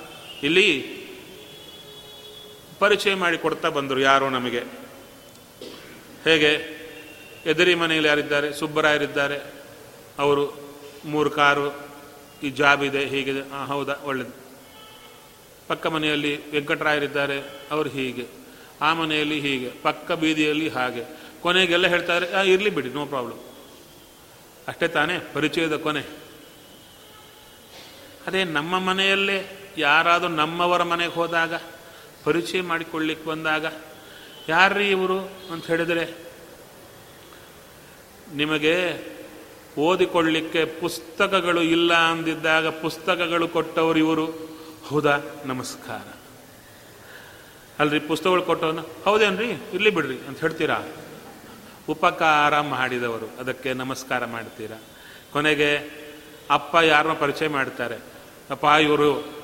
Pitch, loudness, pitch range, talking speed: 155 Hz, -22 LUFS, 145-170 Hz, 85 wpm